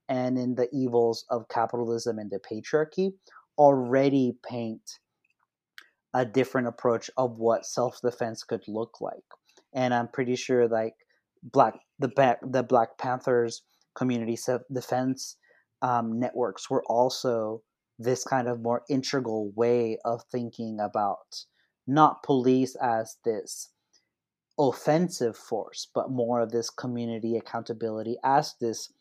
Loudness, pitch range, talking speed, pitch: -28 LUFS, 115-130 Hz, 120 wpm, 120 Hz